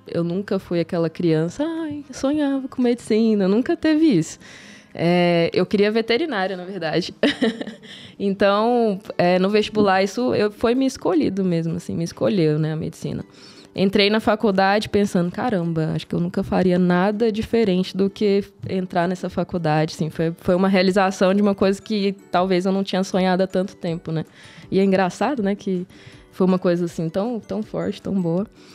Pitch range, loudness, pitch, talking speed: 180-215 Hz, -21 LUFS, 195 Hz, 175 wpm